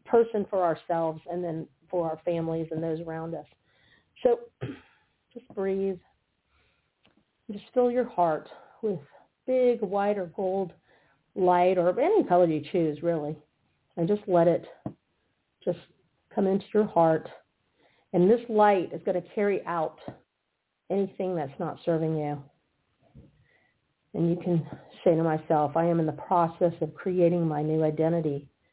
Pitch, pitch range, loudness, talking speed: 175 Hz, 160-195 Hz, -27 LUFS, 145 wpm